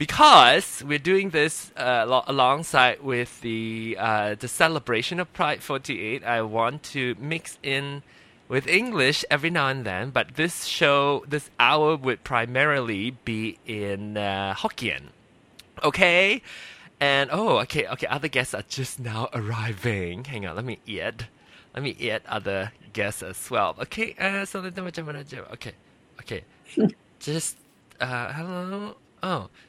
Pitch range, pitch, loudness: 115-160 Hz, 135 Hz, -24 LUFS